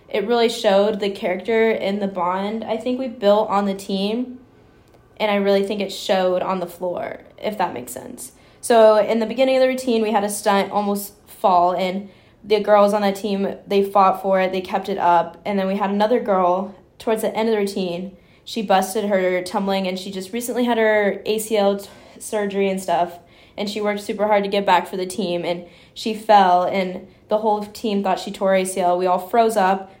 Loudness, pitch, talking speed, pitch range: -20 LUFS, 200 Hz, 215 wpm, 190-215 Hz